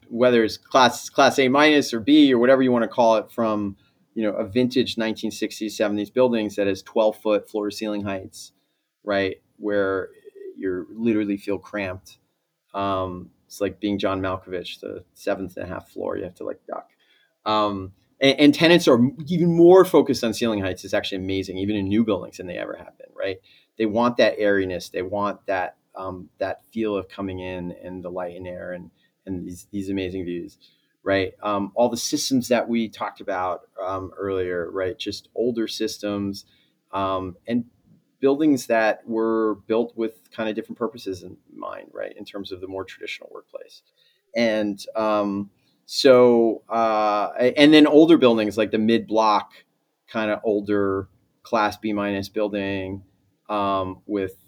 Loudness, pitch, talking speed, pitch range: -22 LUFS, 105 Hz, 175 wpm, 95-120 Hz